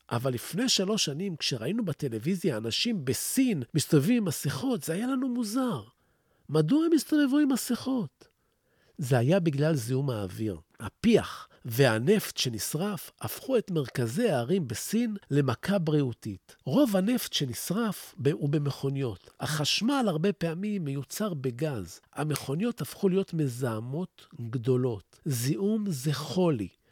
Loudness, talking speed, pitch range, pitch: -29 LUFS, 120 wpm, 135-210 Hz, 155 Hz